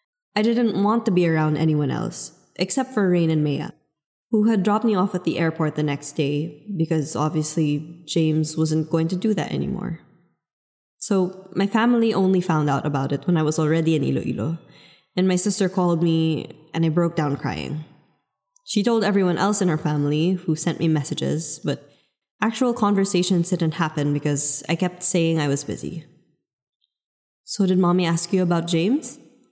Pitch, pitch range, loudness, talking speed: 170 Hz, 155-195 Hz, -22 LUFS, 175 wpm